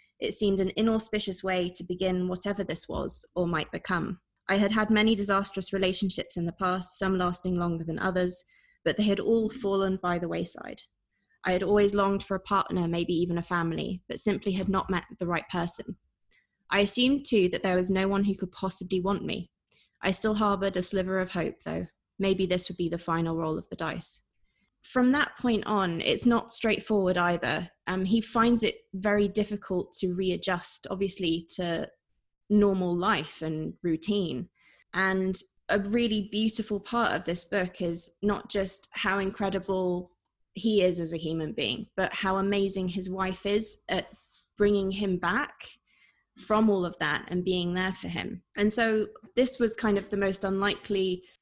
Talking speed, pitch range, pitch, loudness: 180 wpm, 180-205 Hz, 190 Hz, -28 LUFS